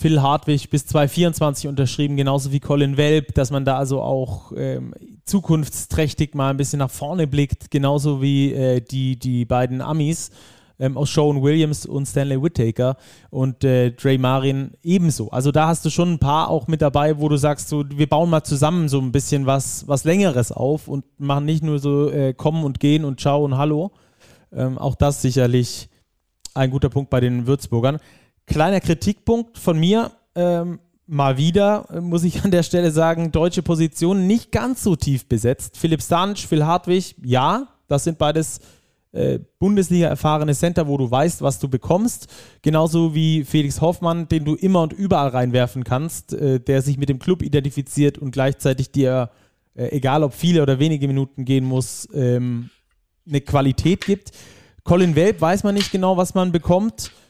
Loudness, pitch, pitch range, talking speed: -19 LUFS, 145 Hz, 135-165 Hz, 180 wpm